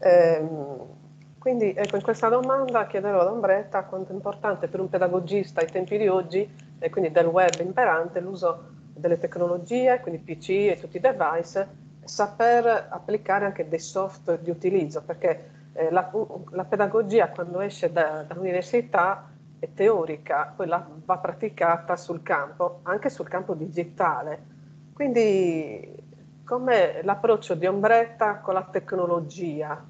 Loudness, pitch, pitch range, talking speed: -25 LUFS, 185 Hz, 165-205 Hz, 135 wpm